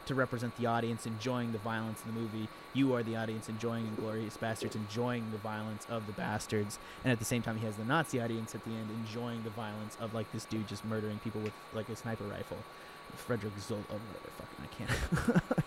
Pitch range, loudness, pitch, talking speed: 110-115 Hz, -37 LUFS, 115 Hz, 225 wpm